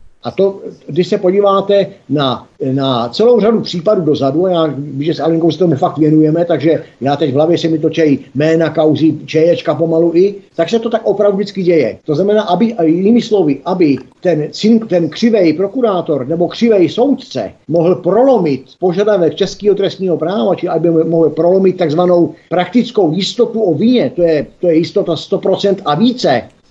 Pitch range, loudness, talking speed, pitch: 160-200 Hz, -13 LUFS, 170 wpm, 175 Hz